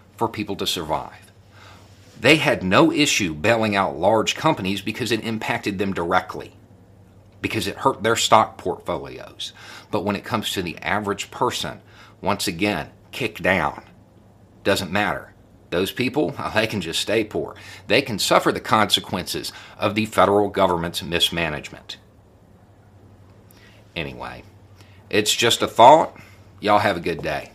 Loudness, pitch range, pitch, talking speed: -21 LUFS, 95-105 Hz, 100 Hz, 140 wpm